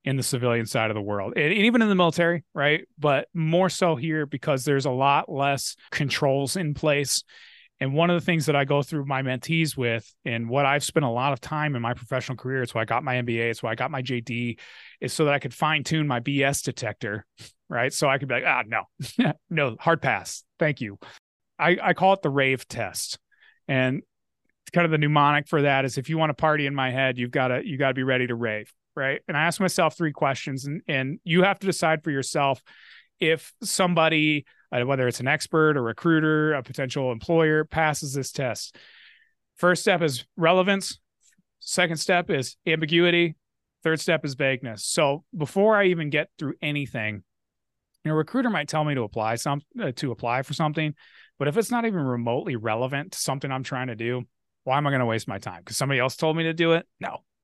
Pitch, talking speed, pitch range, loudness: 145 Hz, 215 wpm, 130-160 Hz, -24 LUFS